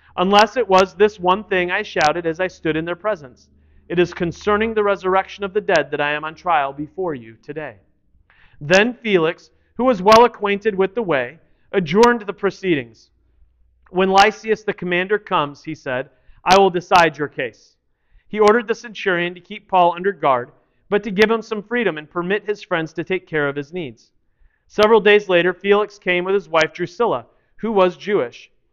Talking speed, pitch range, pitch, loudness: 190 wpm, 155-205 Hz, 185 Hz, -18 LUFS